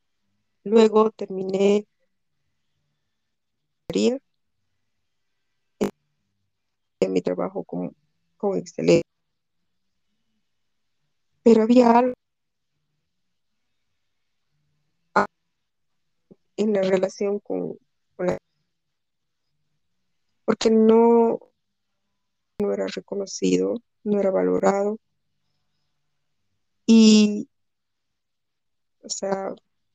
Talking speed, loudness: 55 wpm, -21 LUFS